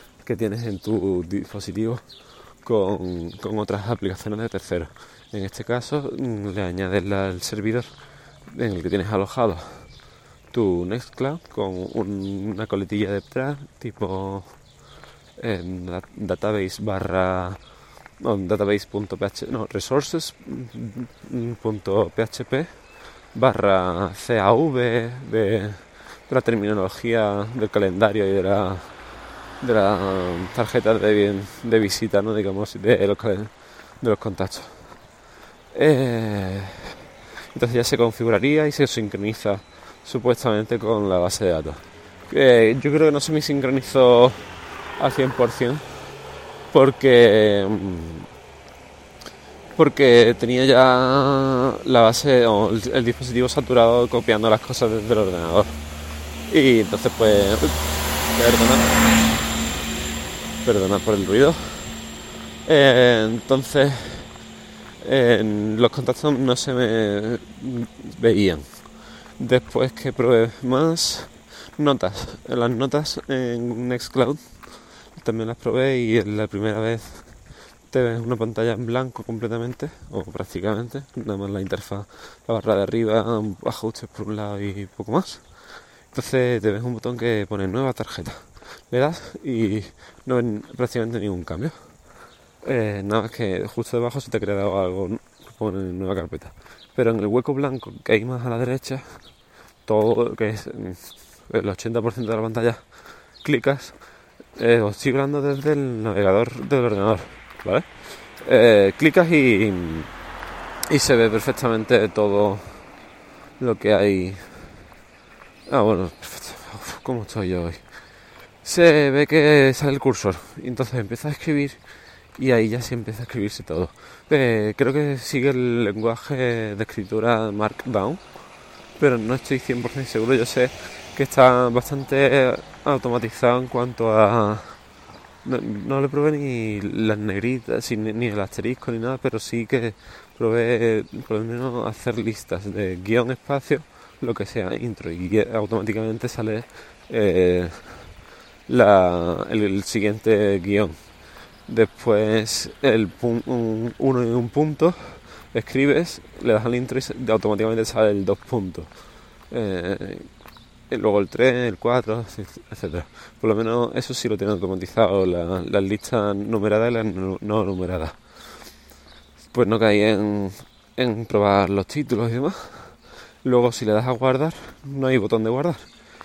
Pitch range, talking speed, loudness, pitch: 100-125 Hz, 130 wpm, -21 LUFS, 110 Hz